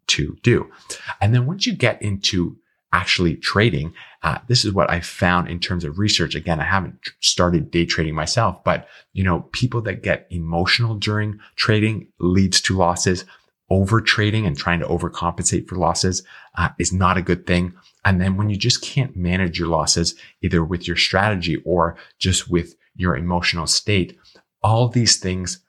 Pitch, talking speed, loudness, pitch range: 90 Hz, 175 wpm, -20 LUFS, 85-105 Hz